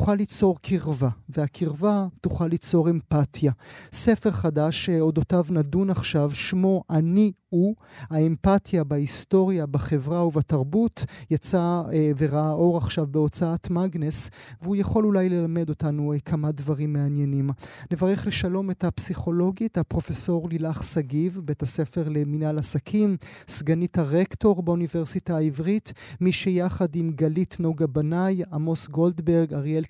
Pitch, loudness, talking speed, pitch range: 165 Hz, -24 LUFS, 115 wpm, 150-180 Hz